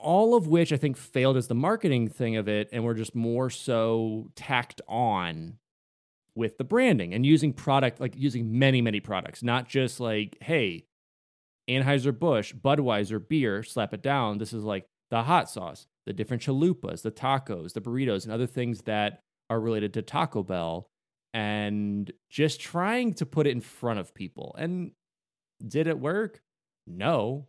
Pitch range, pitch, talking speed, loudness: 110-145 Hz, 120 Hz, 170 wpm, -28 LUFS